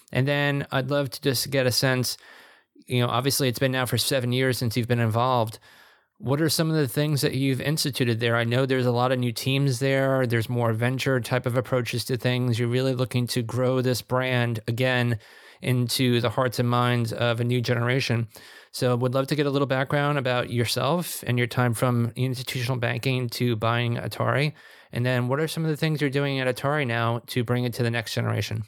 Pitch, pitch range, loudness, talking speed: 125 Hz, 120-135 Hz, -24 LUFS, 220 wpm